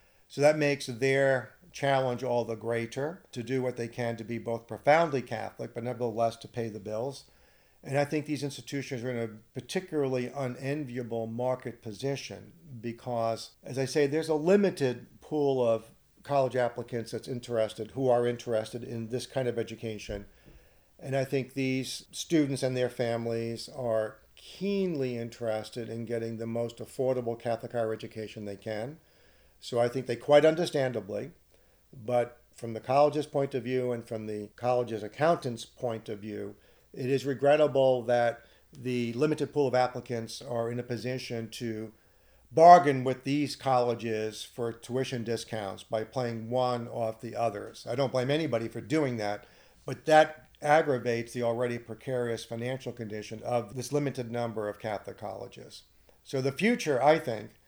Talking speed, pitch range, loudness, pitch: 160 wpm, 115-135 Hz, -30 LUFS, 120 Hz